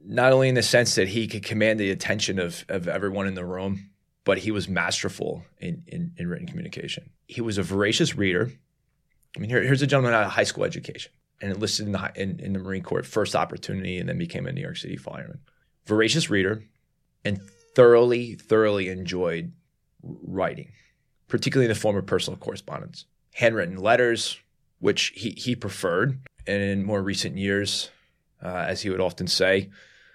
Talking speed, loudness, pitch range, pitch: 185 wpm, -25 LUFS, 100-140 Hz, 110 Hz